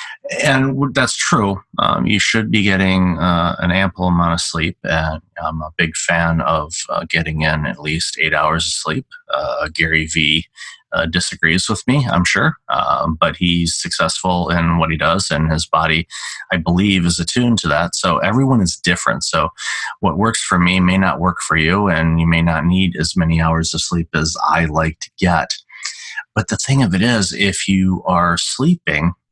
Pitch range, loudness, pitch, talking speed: 80-95 Hz, -16 LUFS, 85 Hz, 190 wpm